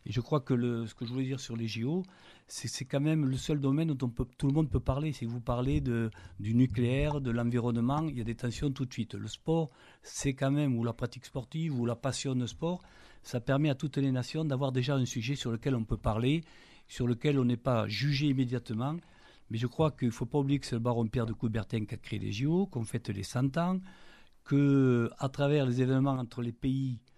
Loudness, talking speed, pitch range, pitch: -32 LUFS, 250 wpm, 120-140 Hz, 130 Hz